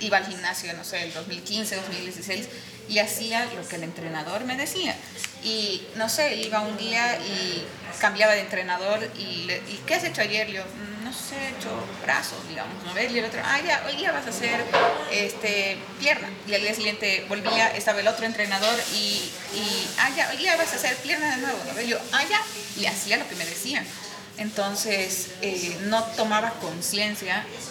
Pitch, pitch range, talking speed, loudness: 210 Hz, 195-230 Hz, 190 wpm, -25 LUFS